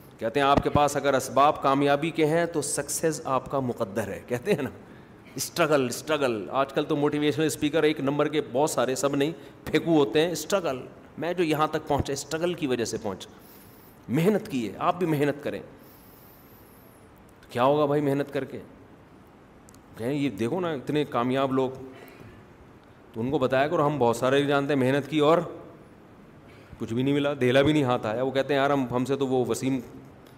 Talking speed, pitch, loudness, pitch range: 195 wpm, 140 Hz, -26 LUFS, 130-150 Hz